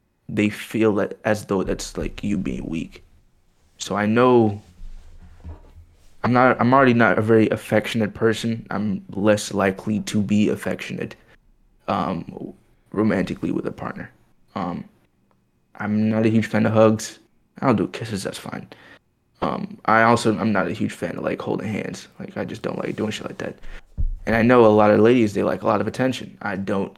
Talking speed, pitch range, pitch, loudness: 180 wpm, 95-110 Hz, 105 Hz, -21 LUFS